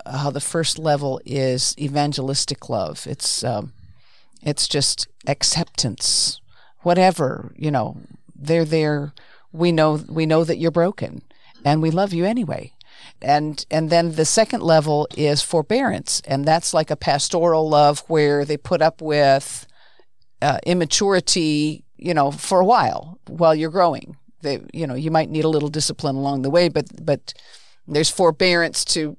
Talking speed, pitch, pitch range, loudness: 155 wpm, 155 Hz, 145-170 Hz, -19 LUFS